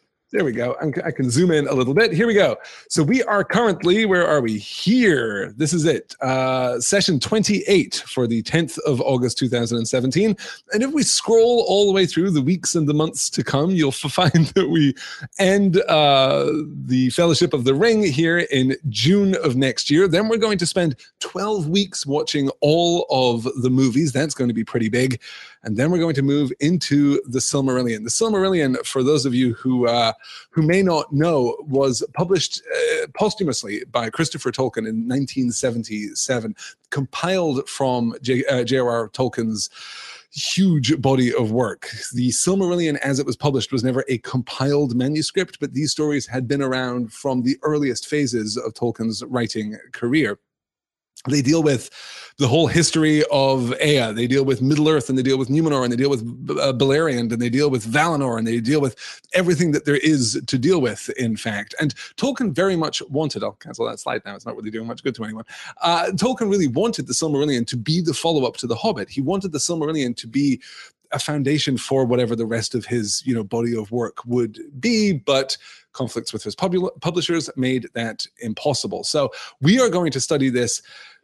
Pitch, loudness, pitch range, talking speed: 140 Hz, -20 LUFS, 125-170 Hz, 190 wpm